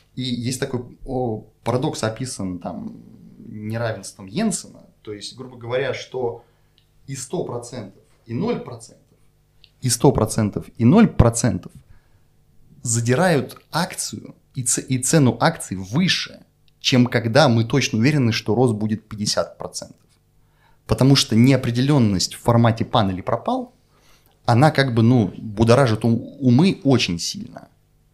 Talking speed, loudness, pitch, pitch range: 115 wpm, -20 LUFS, 120 Hz, 110-135 Hz